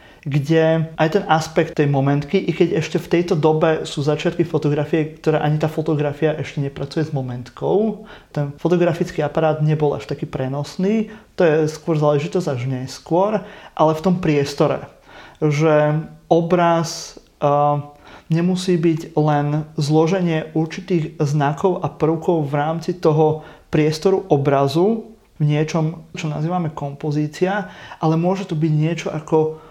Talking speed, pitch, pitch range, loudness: 135 wpm, 155 Hz, 150-170 Hz, -19 LUFS